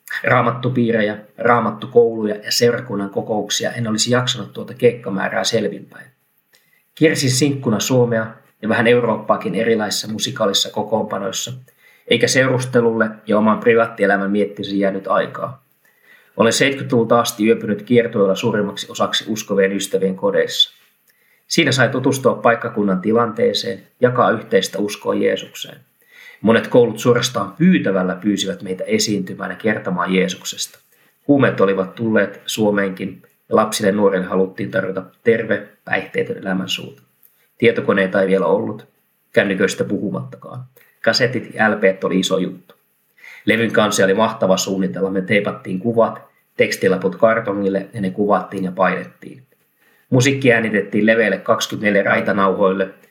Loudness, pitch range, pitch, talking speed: -17 LUFS, 95-120 Hz, 105 Hz, 115 wpm